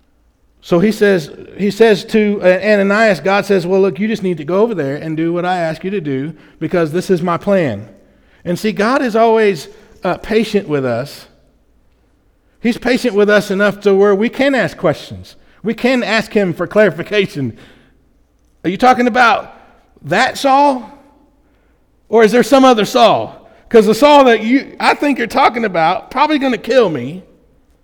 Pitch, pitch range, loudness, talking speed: 205 Hz, 175-245 Hz, -13 LUFS, 180 wpm